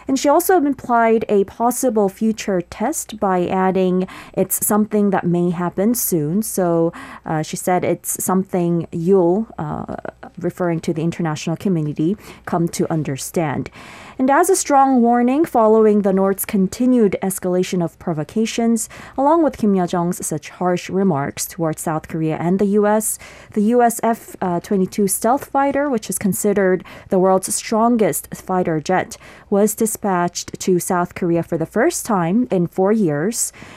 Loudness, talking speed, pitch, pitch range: -18 LUFS, 145 wpm, 195 Hz, 175-225 Hz